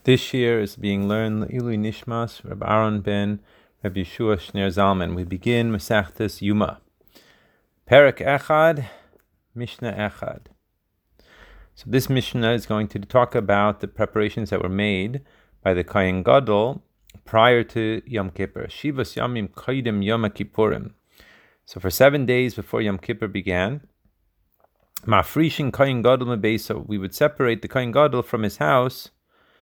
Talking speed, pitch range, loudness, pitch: 140 wpm, 100-125 Hz, -22 LUFS, 110 Hz